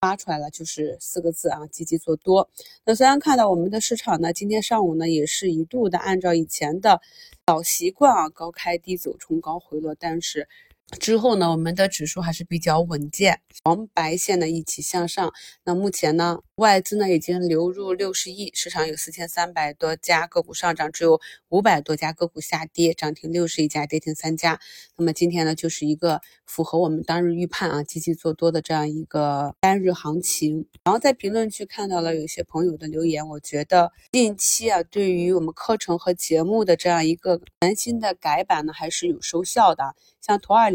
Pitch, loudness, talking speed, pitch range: 170 Hz, -22 LUFS, 300 characters per minute, 160-190 Hz